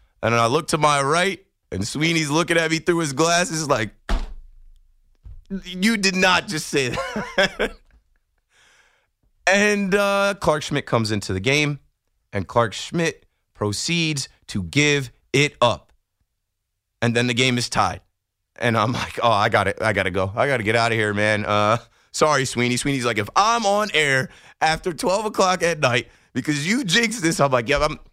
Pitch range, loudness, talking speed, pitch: 105-165 Hz, -20 LUFS, 175 wpm, 135 Hz